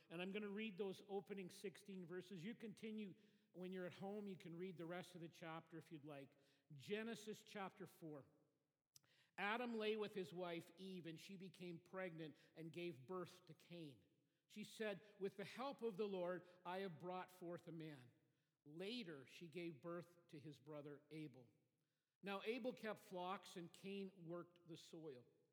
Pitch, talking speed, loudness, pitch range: 180 Hz, 175 wpm, -54 LUFS, 160-195 Hz